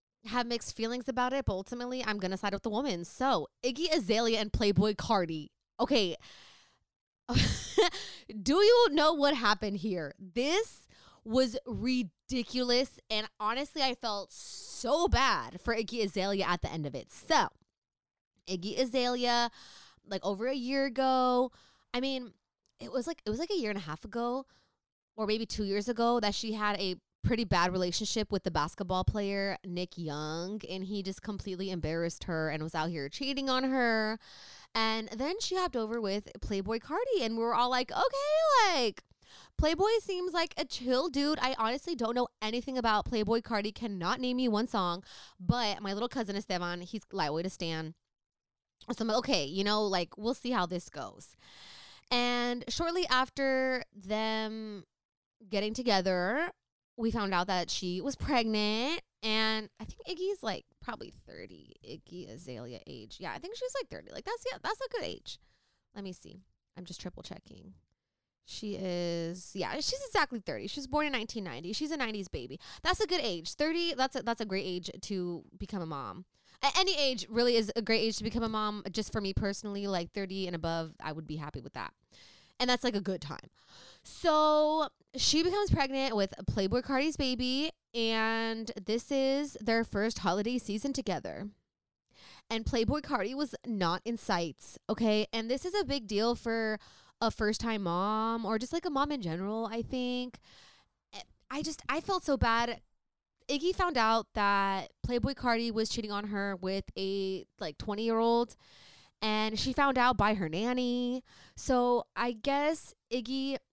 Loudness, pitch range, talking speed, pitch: -32 LUFS, 200-260 Hz, 175 wpm, 225 Hz